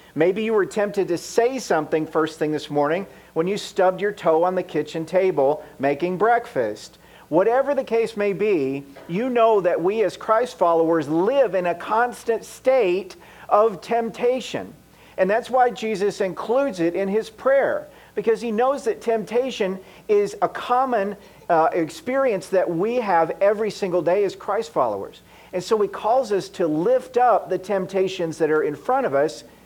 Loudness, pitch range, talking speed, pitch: -22 LUFS, 175-235 Hz, 170 wpm, 200 Hz